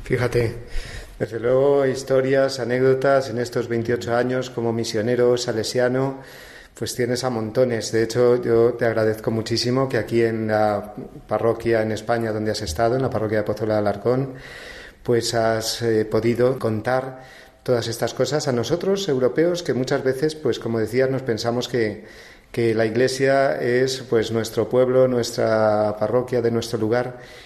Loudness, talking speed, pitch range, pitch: -21 LUFS, 155 wpm, 115-130 Hz, 120 Hz